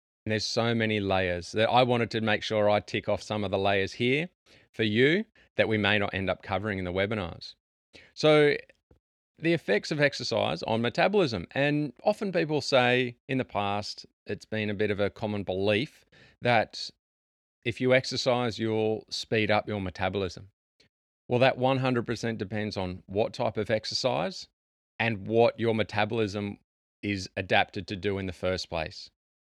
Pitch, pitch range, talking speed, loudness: 110 Hz, 100-125 Hz, 170 wpm, -28 LUFS